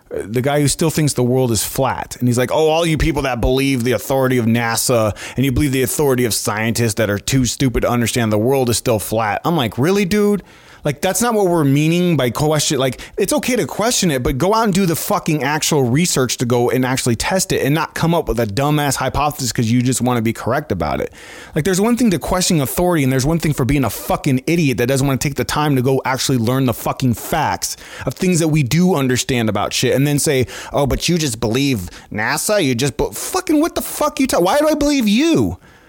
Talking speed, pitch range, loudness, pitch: 255 wpm, 125-170 Hz, -17 LUFS, 135 Hz